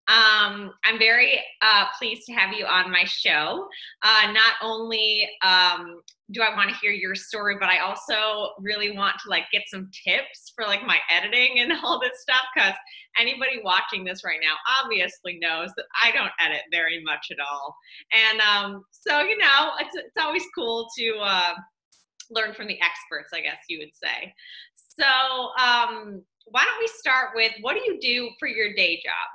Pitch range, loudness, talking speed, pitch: 185-245 Hz, -21 LUFS, 185 wpm, 215 Hz